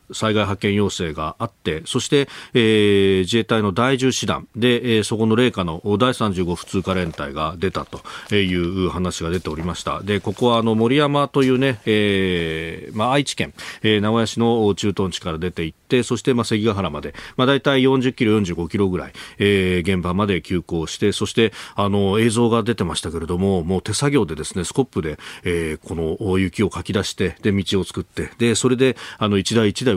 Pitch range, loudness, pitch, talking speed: 90-115 Hz, -20 LUFS, 100 Hz, 360 characters per minute